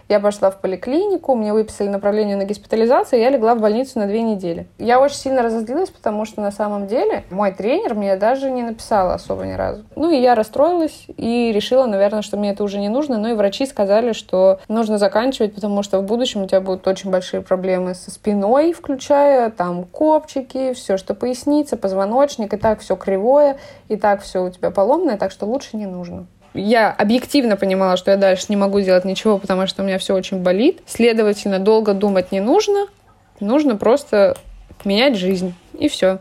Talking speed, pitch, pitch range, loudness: 195 wpm, 215 Hz, 195-260 Hz, -18 LUFS